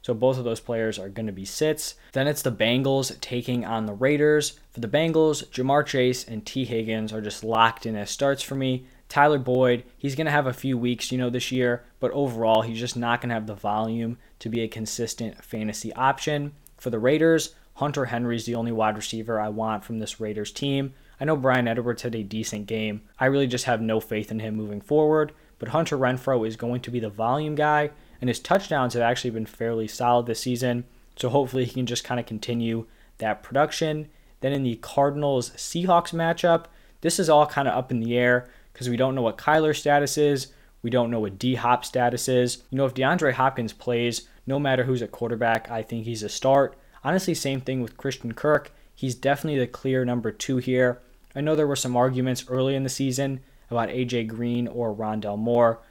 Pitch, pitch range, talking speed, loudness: 125 Hz, 115-140 Hz, 215 wpm, -25 LUFS